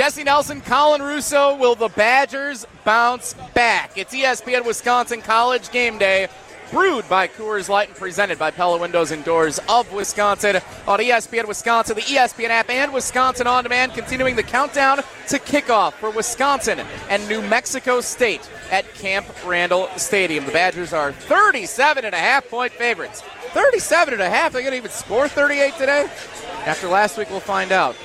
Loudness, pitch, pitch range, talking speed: -18 LUFS, 230 Hz, 200-270 Hz, 165 wpm